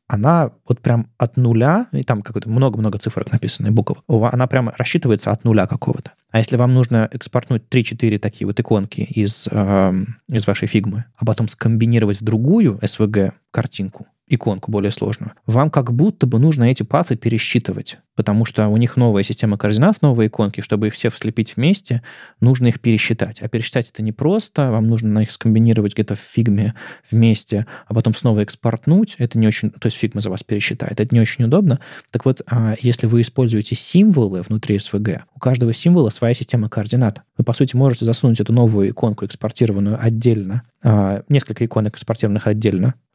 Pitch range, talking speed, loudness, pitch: 105-125 Hz, 175 wpm, -17 LUFS, 115 Hz